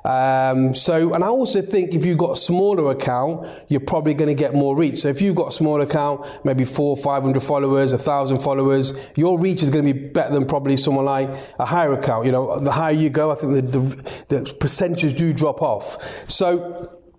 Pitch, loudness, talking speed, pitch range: 145 Hz, -19 LUFS, 225 wpm, 135-165 Hz